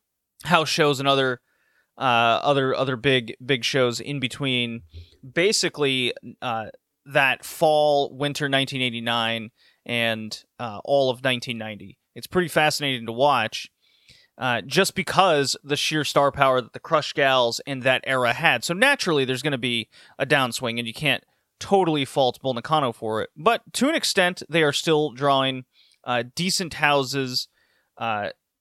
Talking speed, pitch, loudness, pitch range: 145 wpm, 135 Hz, -22 LUFS, 120-150 Hz